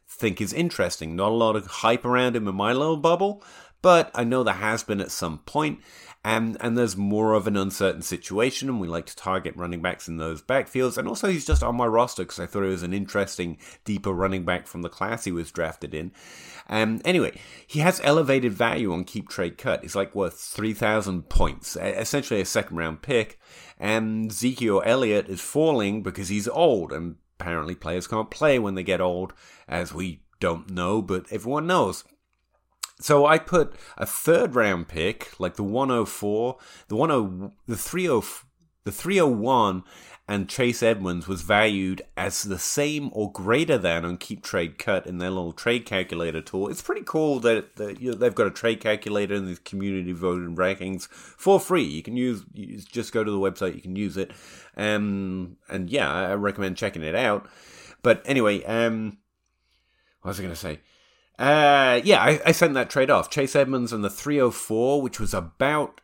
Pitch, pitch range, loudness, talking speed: 105 Hz, 90-120 Hz, -24 LUFS, 200 wpm